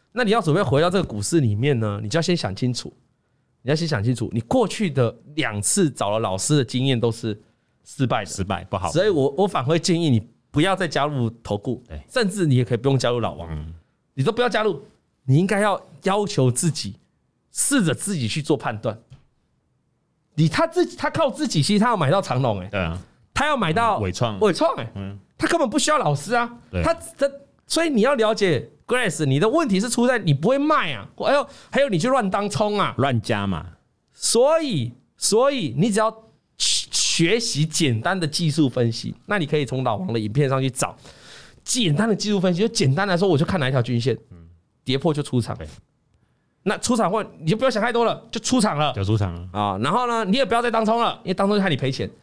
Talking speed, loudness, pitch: 315 characters per minute, -21 LUFS, 155 Hz